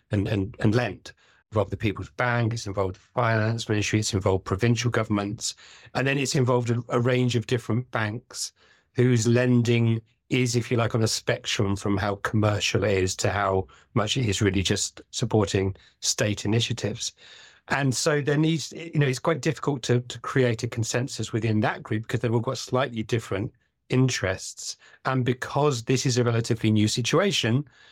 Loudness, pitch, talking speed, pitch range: -25 LUFS, 120 Hz, 180 wpm, 105-125 Hz